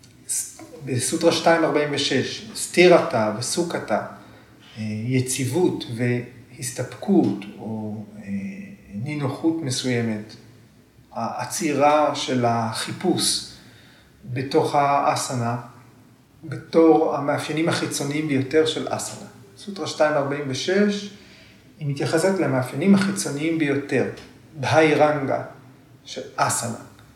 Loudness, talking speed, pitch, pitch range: -22 LUFS, 70 wpm, 140 Hz, 125-155 Hz